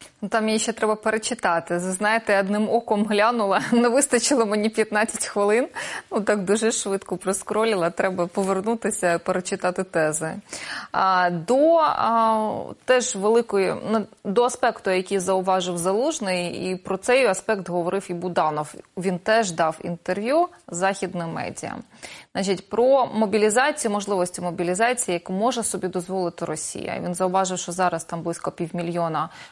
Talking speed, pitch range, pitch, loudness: 130 wpm, 180-220 Hz, 195 Hz, -23 LUFS